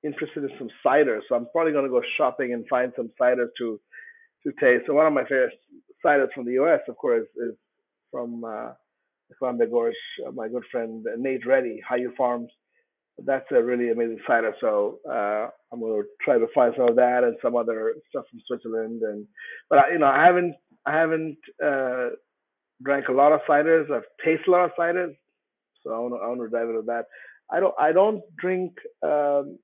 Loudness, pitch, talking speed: -24 LUFS, 155 Hz, 195 wpm